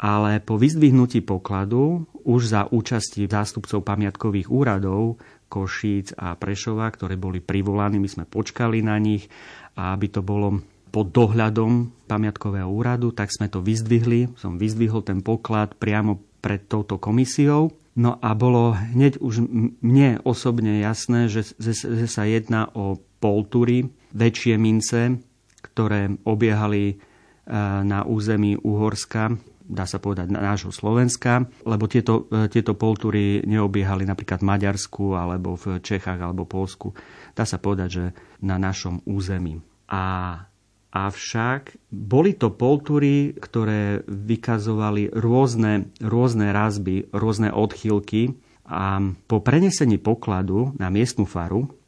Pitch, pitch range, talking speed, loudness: 105 Hz, 100-115 Hz, 125 wpm, -22 LUFS